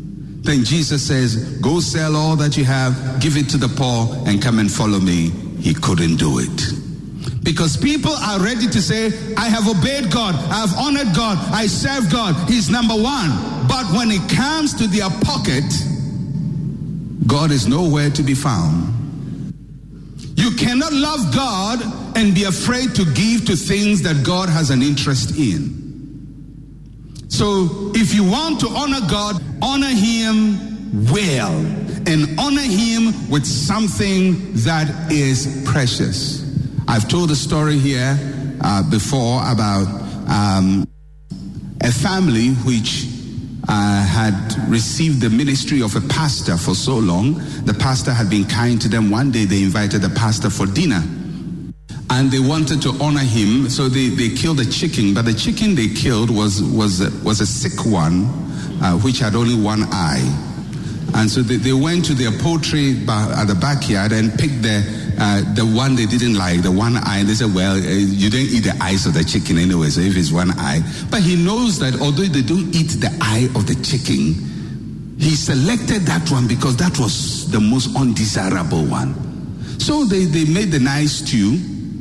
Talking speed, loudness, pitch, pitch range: 170 wpm, -17 LUFS, 140 Hz, 115-175 Hz